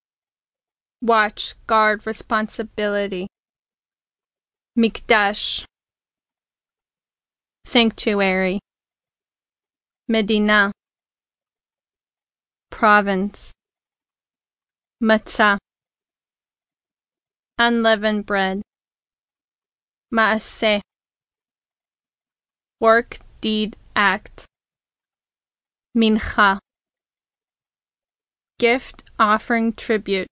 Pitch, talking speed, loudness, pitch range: 215 Hz, 35 wpm, -19 LUFS, 205-225 Hz